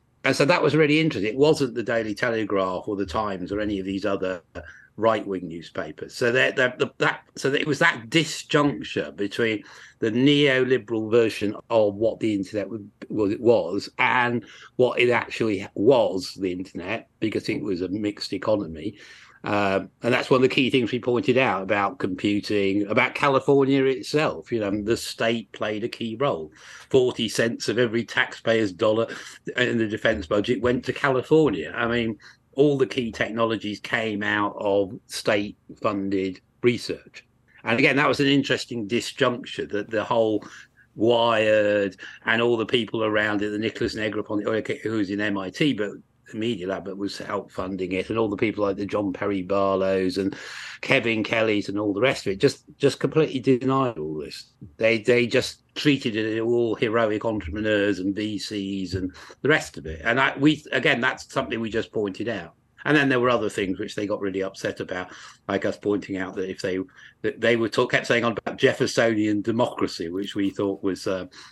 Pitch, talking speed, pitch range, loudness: 110 Hz, 185 wpm, 100-125 Hz, -24 LUFS